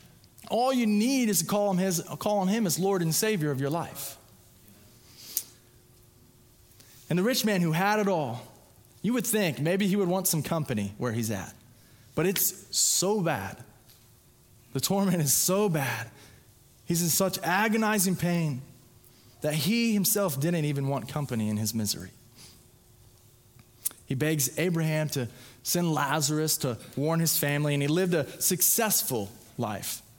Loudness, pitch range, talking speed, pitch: -27 LUFS, 120-185 Hz, 150 wpm, 150 Hz